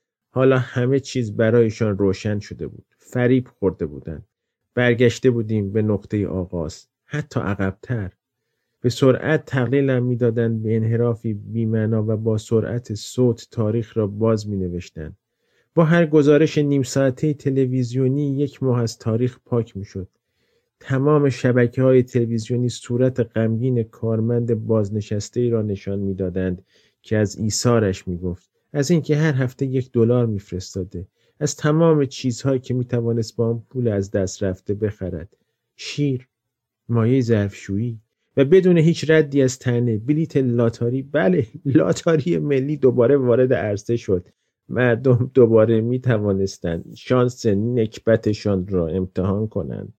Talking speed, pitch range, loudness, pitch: 130 wpm, 105-130 Hz, -20 LUFS, 120 Hz